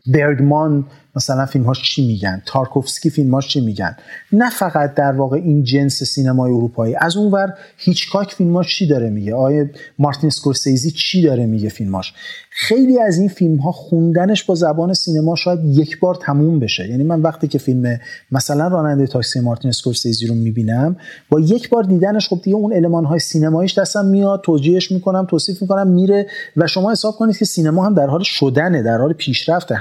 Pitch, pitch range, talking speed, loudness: 155 Hz, 135-185 Hz, 180 wpm, -16 LUFS